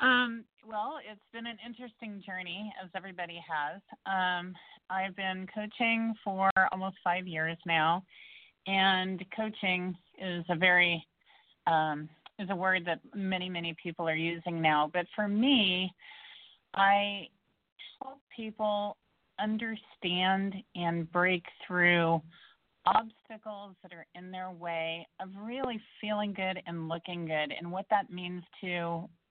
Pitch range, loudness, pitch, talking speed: 175-210 Hz, -31 LUFS, 190 Hz, 130 wpm